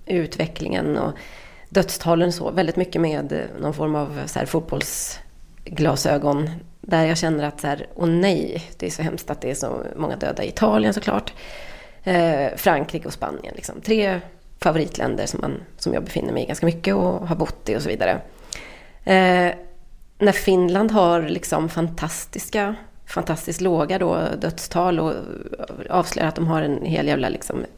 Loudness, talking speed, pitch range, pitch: -22 LUFS, 165 wpm, 160-185 Hz, 170 Hz